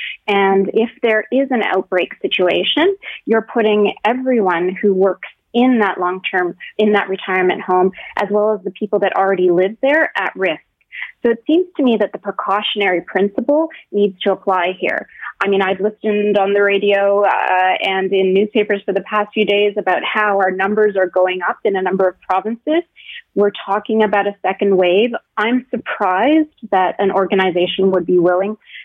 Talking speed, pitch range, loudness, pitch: 180 wpm, 190-220 Hz, -16 LUFS, 200 Hz